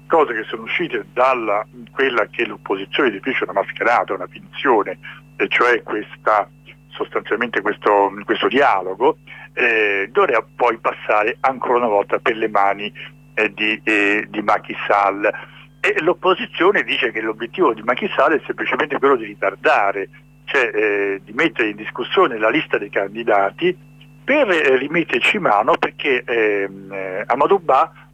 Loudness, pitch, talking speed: -18 LUFS, 110 Hz, 135 wpm